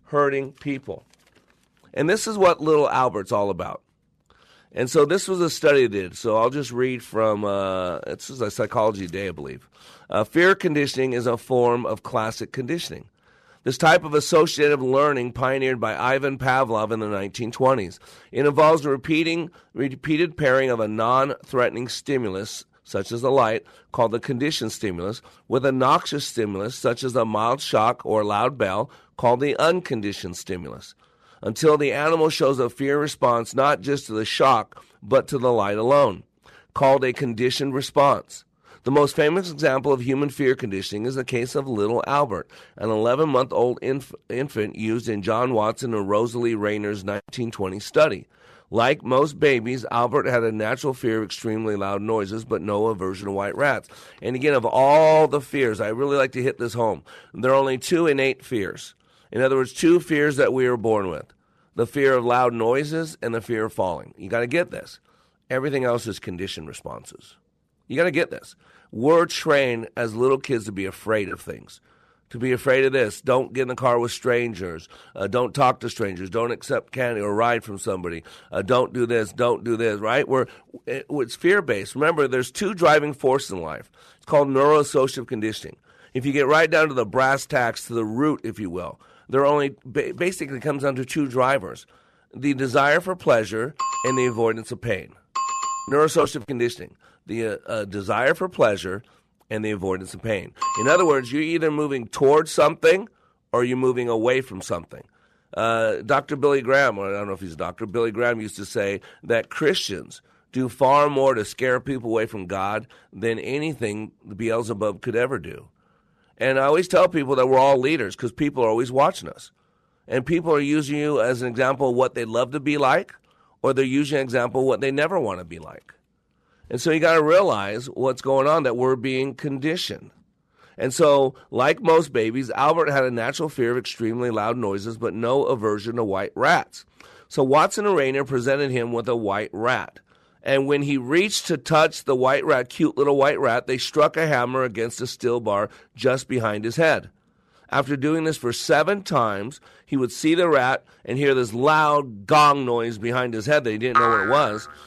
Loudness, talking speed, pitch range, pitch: -22 LUFS, 190 wpm, 115-145 Hz, 130 Hz